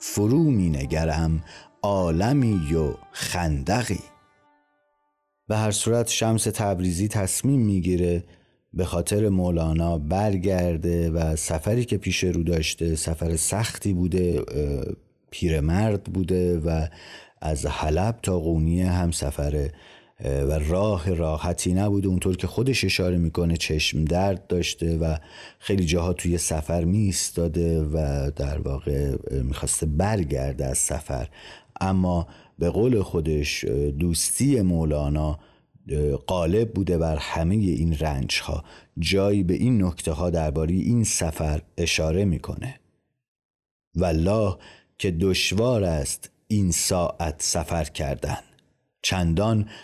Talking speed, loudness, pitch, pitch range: 110 wpm, -24 LUFS, 85 Hz, 80-100 Hz